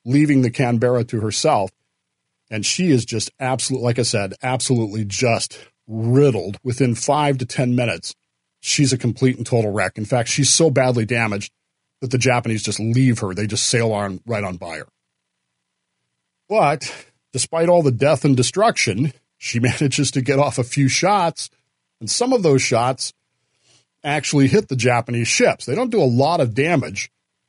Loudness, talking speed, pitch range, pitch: -18 LUFS, 170 wpm, 110-135 Hz, 125 Hz